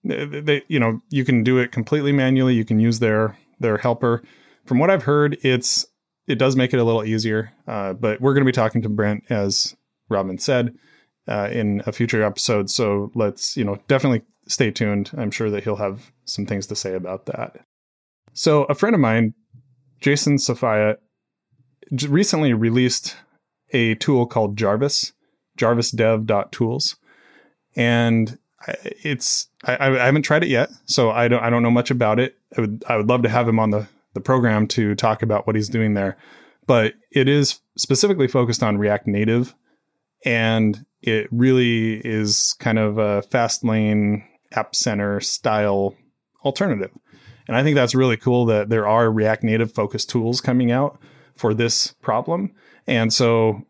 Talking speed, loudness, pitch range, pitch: 170 wpm, -20 LUFS, 105-130 Hz, 115 Hz